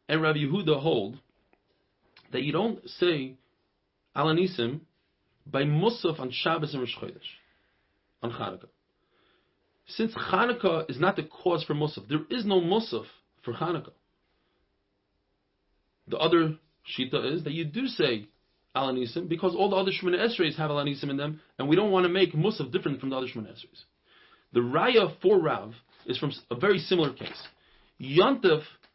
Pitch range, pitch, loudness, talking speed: 125-180 Hz, 155 Hz, -27 LUFS, 155 wpm